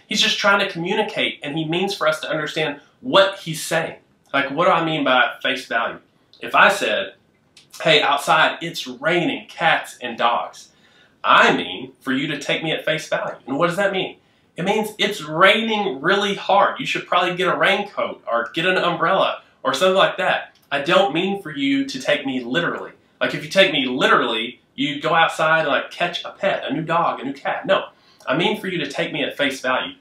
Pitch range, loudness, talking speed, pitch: 160-205 Hz, -19 LUFS, 215 wpm, 185 Hz